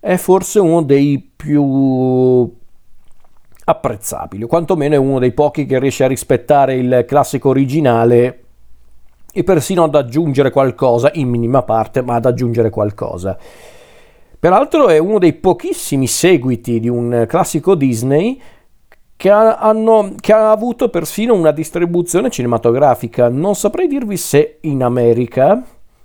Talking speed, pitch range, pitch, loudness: 130 wpm, 120-175 Hz, 140 Hz, -13 LUFS